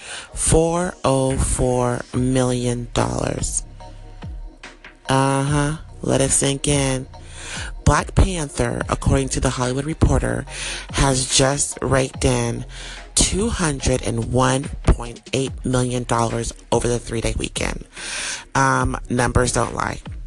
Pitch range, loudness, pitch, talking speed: 120-135 Hz, -20 LUFS, 130 Hz, 90 wpm